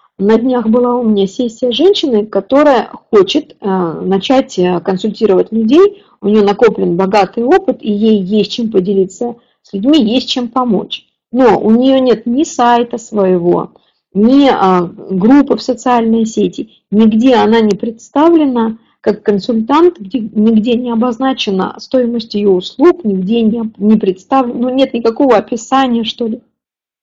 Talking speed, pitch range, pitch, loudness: 135 wpm, 205-255 Hz, 230 Hz, -12 LUFS